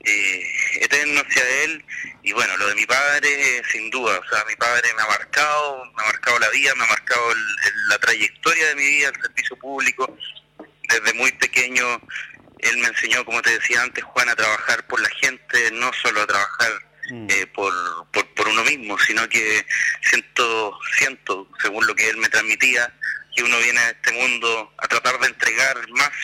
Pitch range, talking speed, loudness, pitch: 125-150 Hz, 195 wpm, -18 LUFS, 130 Hz